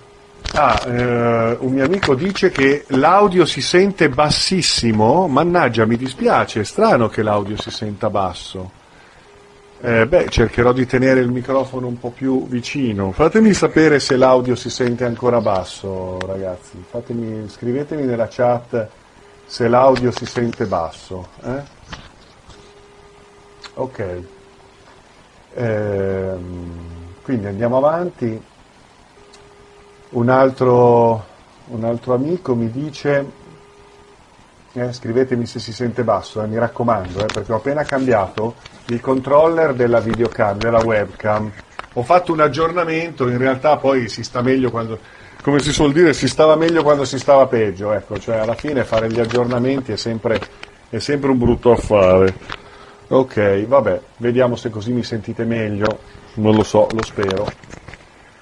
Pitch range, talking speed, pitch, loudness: 110-135 Hz, 135 wpm, 120 Hz, -17 LUFS